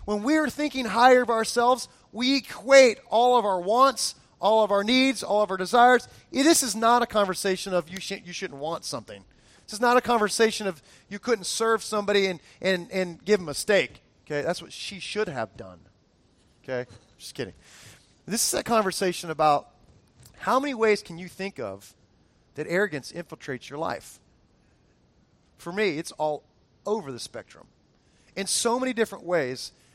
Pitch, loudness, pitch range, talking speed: 200 Hz, -24 LUFS, 165-235 Hz, 180 wpm